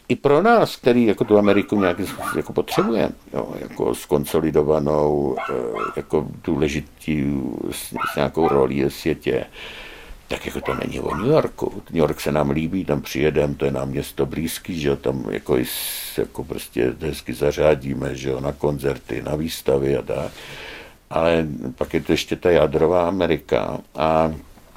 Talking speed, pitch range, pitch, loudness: 155 wpm, 70-80 Hz, 75 Hz, -21 LUFS